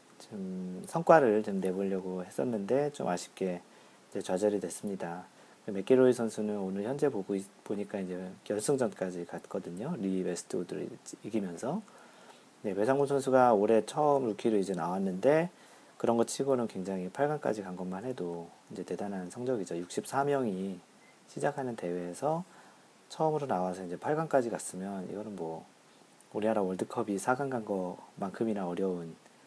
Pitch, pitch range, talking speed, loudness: 100 Hz, 95-130 Hz, 320 characters per minute, -32 LUFS